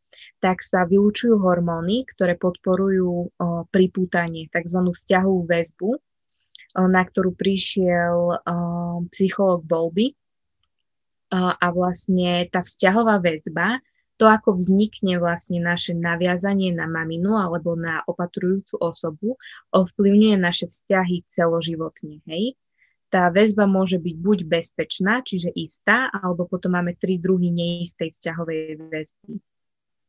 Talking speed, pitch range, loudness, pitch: 110 wpm, 170-195 Hz, -21 LUFS, 180 Hz